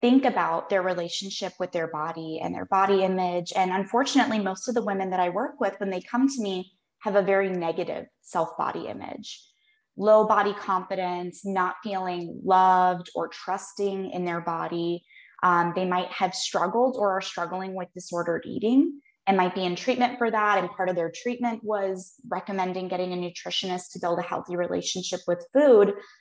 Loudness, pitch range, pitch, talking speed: -26 LUFS, 180-210 Hz, 190 Hz, 180 wpm